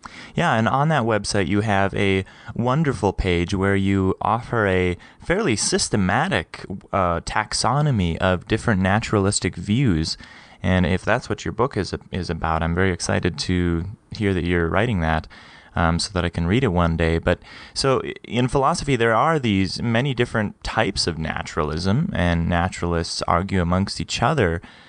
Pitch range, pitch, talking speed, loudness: 85-110 Hz, 95 Hz, 160 wpm, -21 LUFS